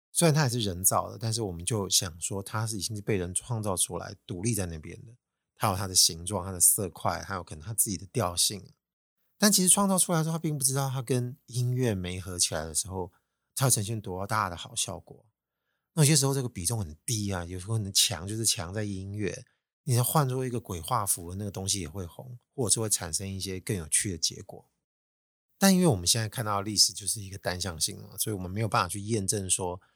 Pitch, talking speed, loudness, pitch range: 105 Hz, 340 characters per minute, -27 LUFS, 95-120 Hz